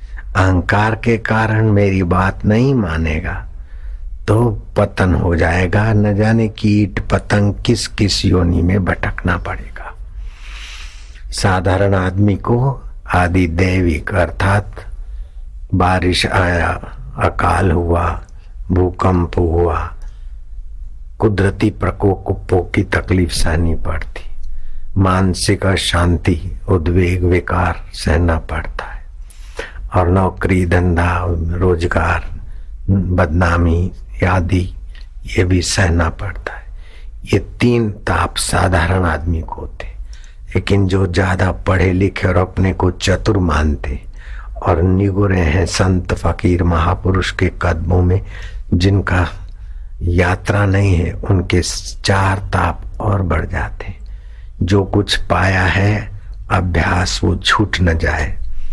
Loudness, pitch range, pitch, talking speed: -16 LUFS, 85-100 Hz, 90 Hz, 105 wpm